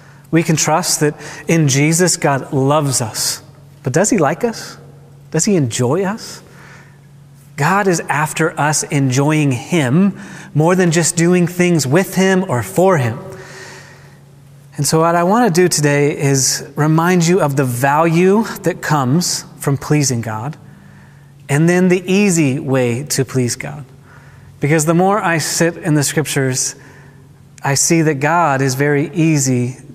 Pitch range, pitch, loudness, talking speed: 140-170 Hz, 150 Hz, -15 LUFS, 150 wpm